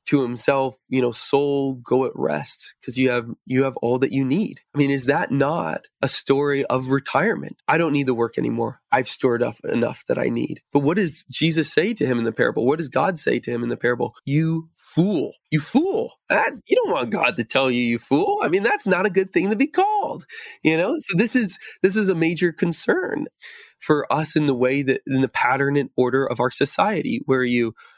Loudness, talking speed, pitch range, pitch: -21 LUFS, 230 wpm, 130-190 Hz, 145 Hz